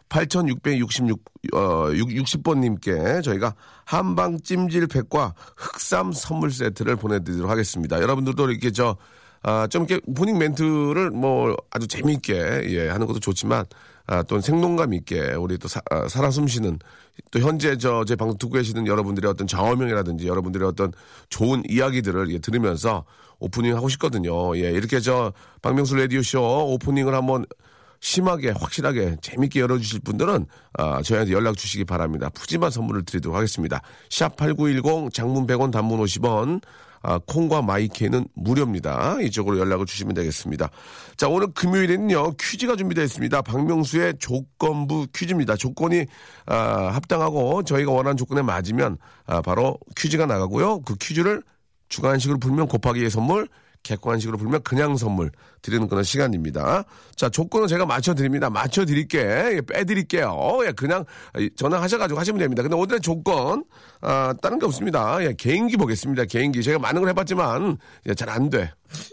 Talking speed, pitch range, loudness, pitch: 355 characters per minute, 105-155 Hz, -23 LUFS, 130 Hz